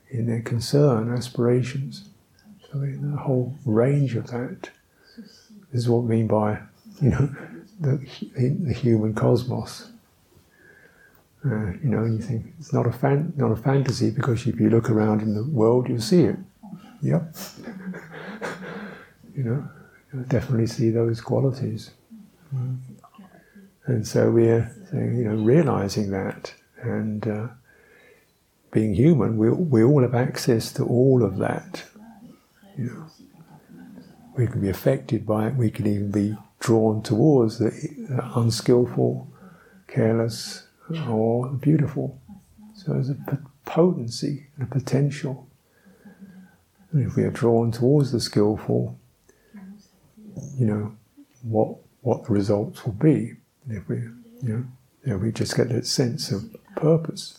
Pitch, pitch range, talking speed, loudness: 125 Hz, 115-150 Hz, 135 wpm, -23 LUFS